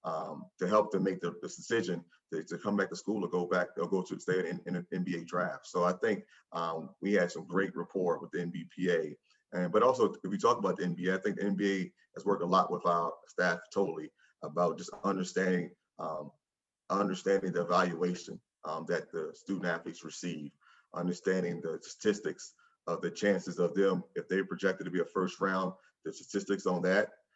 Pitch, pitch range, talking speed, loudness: 90 Hz, 90-95 Hz, 205 wpm, -33 LUFS